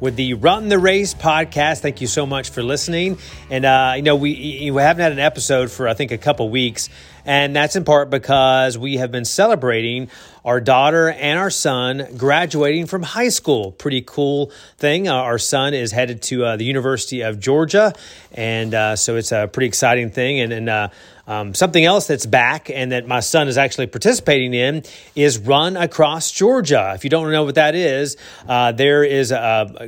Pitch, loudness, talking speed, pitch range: 135 Hz, -17 LUFS, 200 wpm, 125-150 Hz